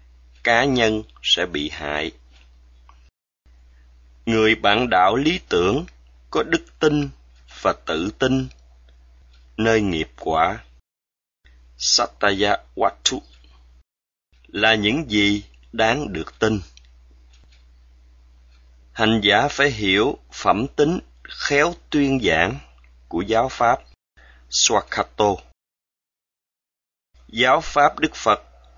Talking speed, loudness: 90 wpm, -20 LUFS